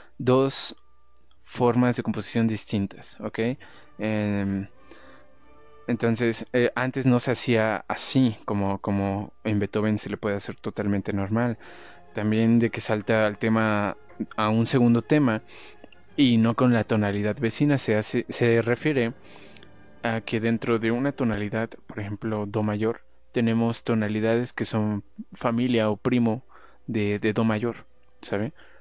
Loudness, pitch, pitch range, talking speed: -25 LUFS, 110 Hz, 105-120 Hz, 135 wpm